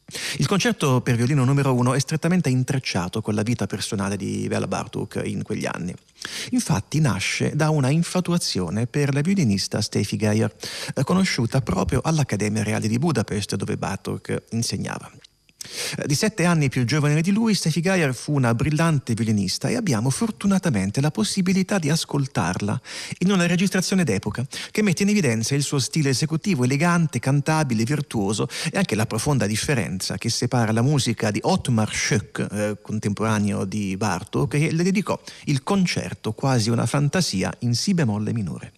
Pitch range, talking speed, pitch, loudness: 110-165 Hz, 155 wpm, 135 Hz, -22 LUFS